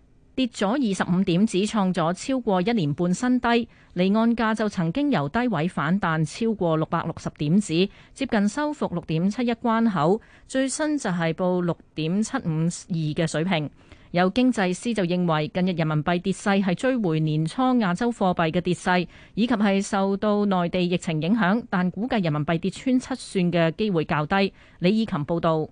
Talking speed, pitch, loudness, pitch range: 270 characters per minute, 185 Hz, -24 LUFS, 170-225 Hz